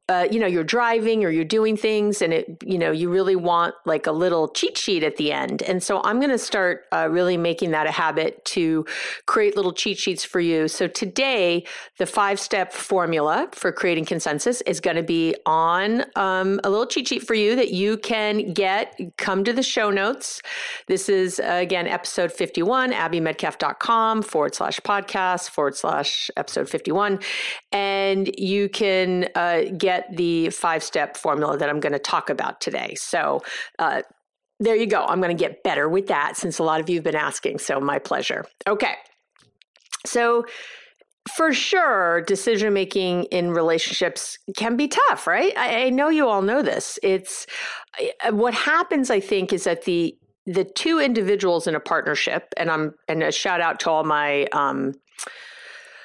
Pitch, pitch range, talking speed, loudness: 190 Hz, 170-225 Hz, 180 wpm, -22 LUFS